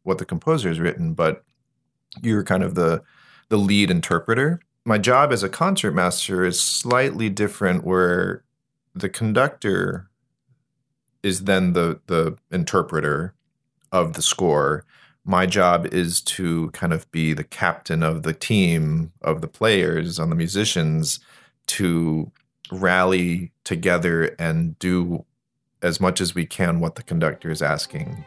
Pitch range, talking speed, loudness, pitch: 85-115 Hz, 140 wpm, -21 LUFS, 90 Hz